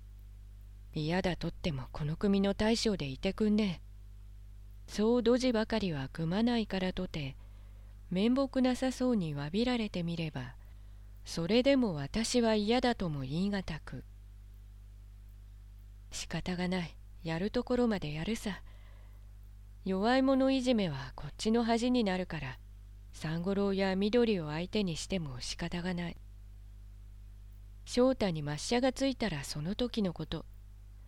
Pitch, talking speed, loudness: 165 Hz, 255 characters per minute, -33 LUFS